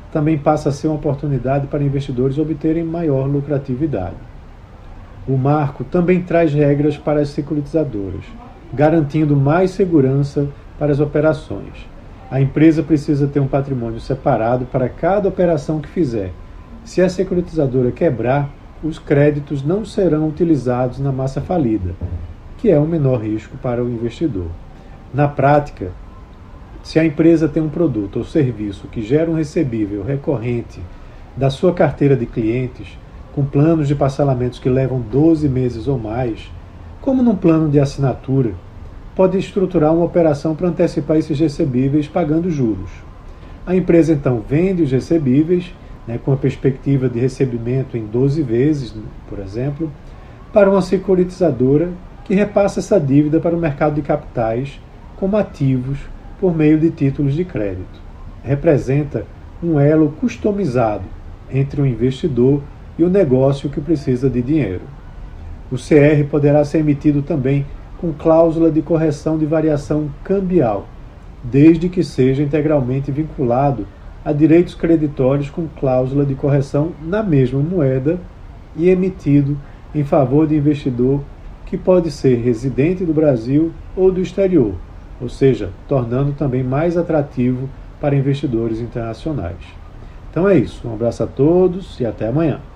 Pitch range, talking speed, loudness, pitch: 120-160 Hz, 140 wpm, -17 LUFS, 140 Hz